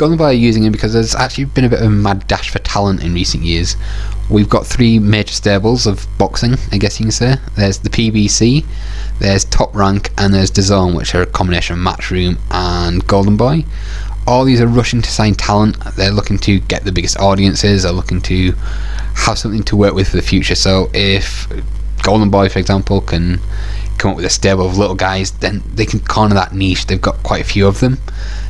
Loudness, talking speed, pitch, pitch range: -13 LUFS, 215 wpm, 100 Hz, 95-110 Hz